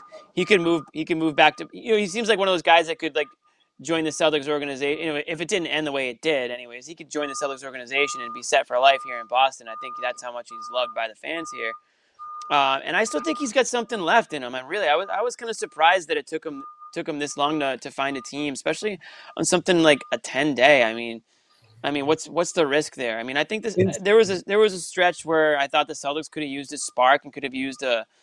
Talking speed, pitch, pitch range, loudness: 290 wpm, 160 Hz, 145-220 Hz, -23 LUFS